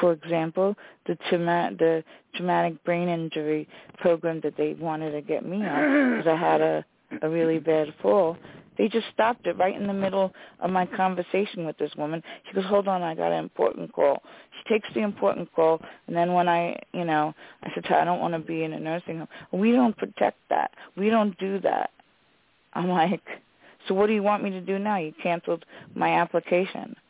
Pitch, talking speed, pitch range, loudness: 175 Hz, 210 wpm, 160-200 Hz, -26 LUFS